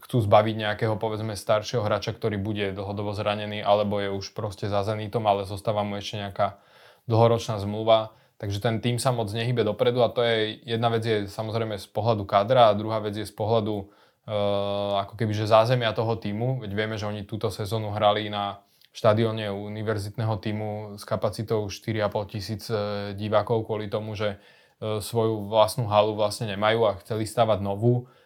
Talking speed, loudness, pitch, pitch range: 175 wpm, -26 LUFS, 110 Hz, 105-115 Hz